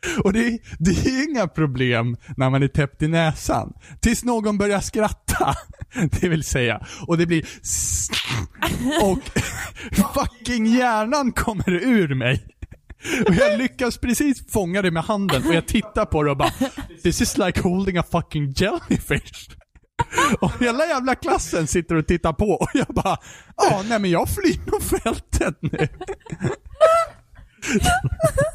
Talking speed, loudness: 145 wpm, -21 LUFS